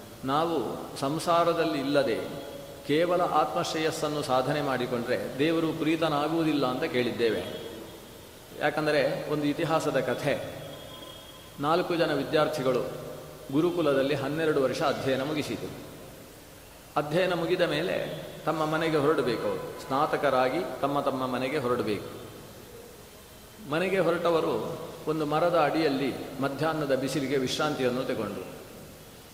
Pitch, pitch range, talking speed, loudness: 150 Hz, 135-160 Hz, 90 wpm, -28 LUFS